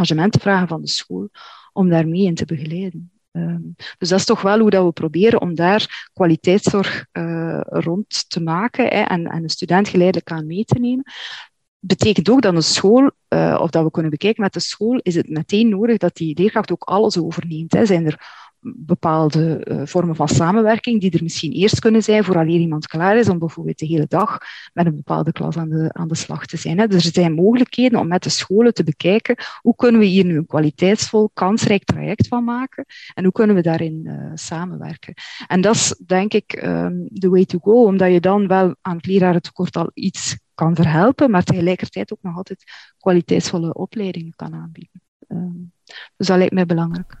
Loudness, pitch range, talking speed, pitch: -17 LUFS, 165-205 Hz, 205 wpm, 180 Hz